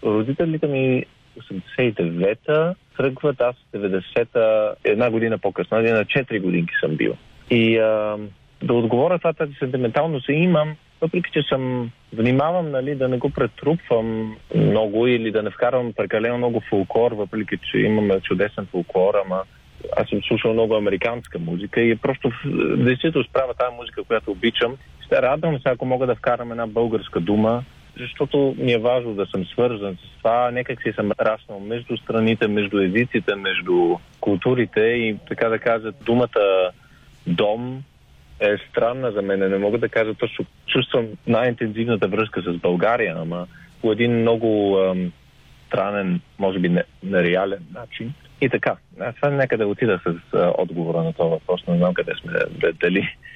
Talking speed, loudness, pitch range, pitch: 155 wpm, -21 LUFS, 105-130 Hz, 115 Hz